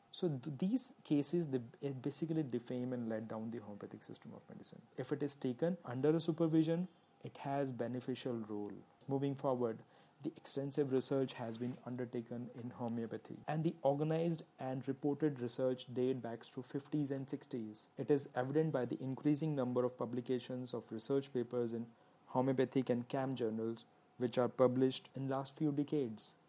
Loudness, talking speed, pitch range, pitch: -39 LUFS, 165 wpm, 120-145 Hz, 130 Hz